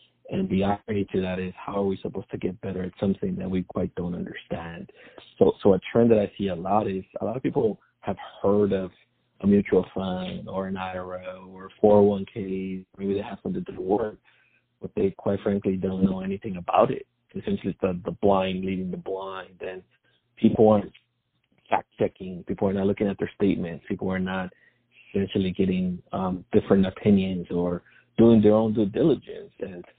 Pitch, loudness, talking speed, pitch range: 95 Hz, -25 LUFS, 190 wpm, 95-100 Hz